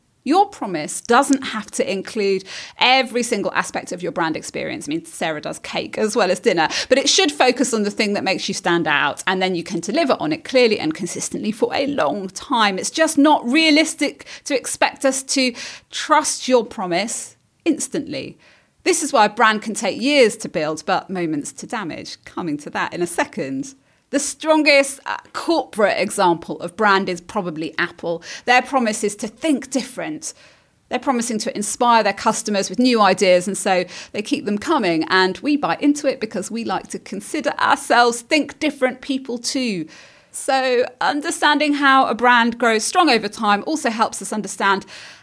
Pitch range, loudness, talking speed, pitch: 195-275 Hz, -19 LUFS, 185 wpm, 240 Hz